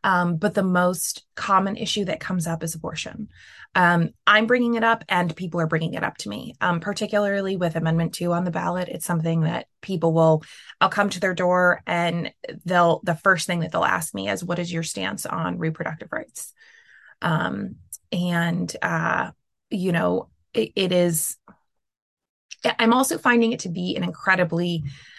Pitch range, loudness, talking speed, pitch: 165-195 Hz, -23 LUFS, 180 wpm, 175 Hz